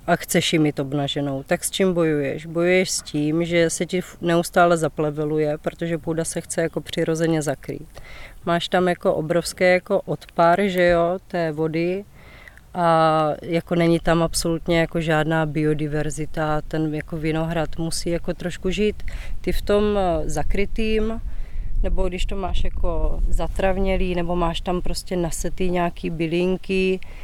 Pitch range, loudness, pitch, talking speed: 160-180 Hz, -22 LUFS, 170 Hz, 145 wpm